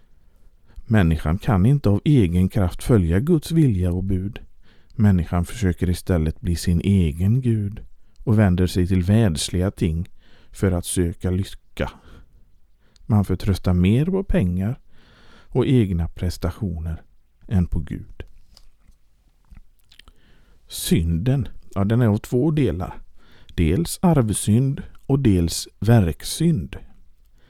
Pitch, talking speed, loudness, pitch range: 95 Hz, 110 wpm, -21 LUFS, 85-115 Hz